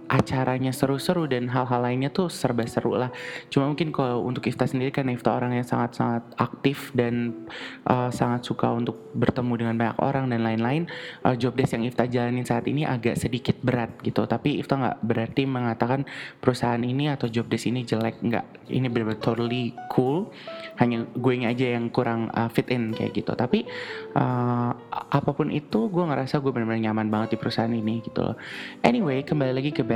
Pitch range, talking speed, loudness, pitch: 115-135 Hz, 175 wpm, -26 LUFS, 125 Hz